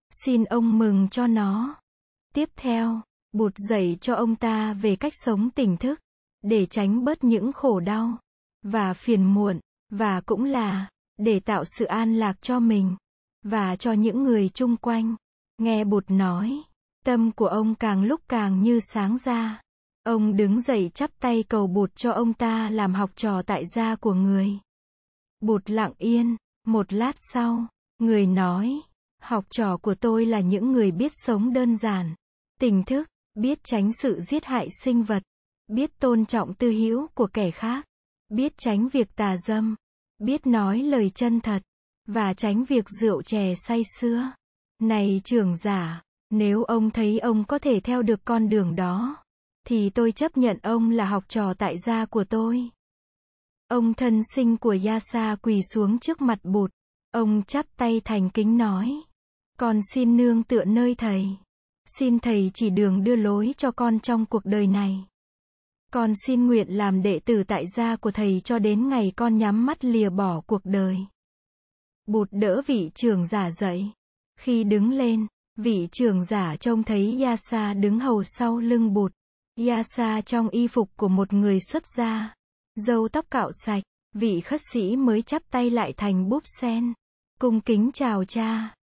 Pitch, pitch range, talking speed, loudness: 225 Hz, 205-240 Hz, 170 wpm, -24 LUFS